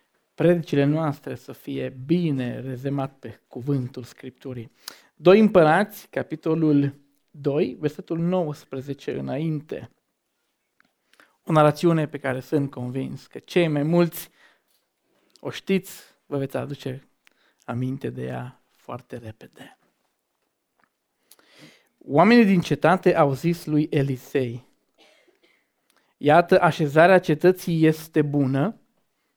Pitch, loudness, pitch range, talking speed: 150 Hz, -22 LUFS, 135-170 Hz, 100 wpm